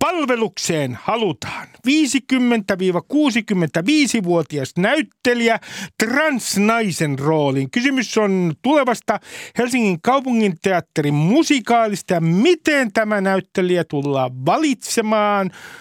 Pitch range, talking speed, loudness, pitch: 175-255 Hz, 70 wpm, -18 LUFS, 215 Hz